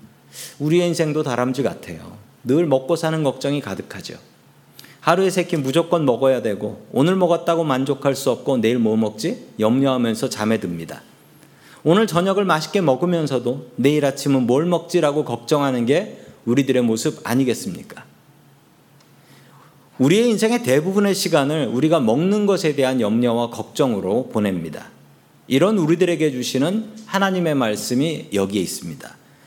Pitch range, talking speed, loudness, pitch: 125-170 Hz, 330 characters per minute, -19 LUFS, 145 Hz